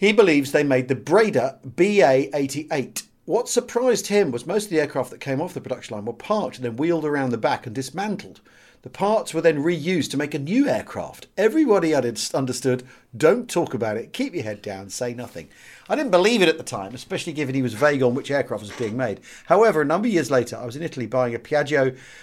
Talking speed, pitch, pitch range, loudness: 225 wpm, 140 Hz, 125-175 Hz, -22 LUFS